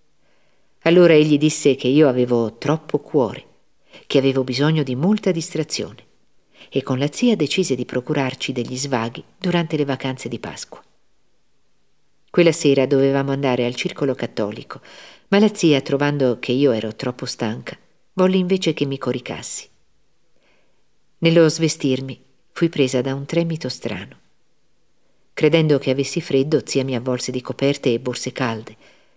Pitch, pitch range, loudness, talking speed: 135 Hz, 125-155 Hz, -19 LUFS, 140 wpm